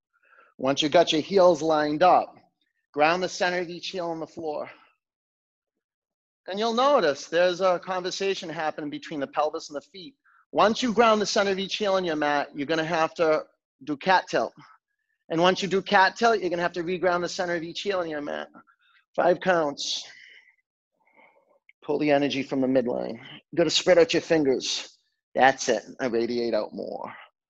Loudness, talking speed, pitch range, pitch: -24 LUFS, 190 wpm, 155-195 Hz, 175 Hz